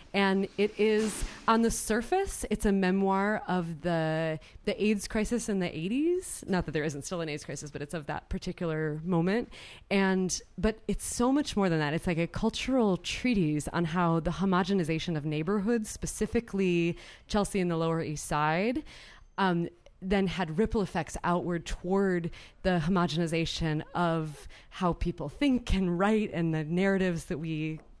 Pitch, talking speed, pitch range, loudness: 180 Hz, 165 wpm, 165-205 Hz, -30 LUFS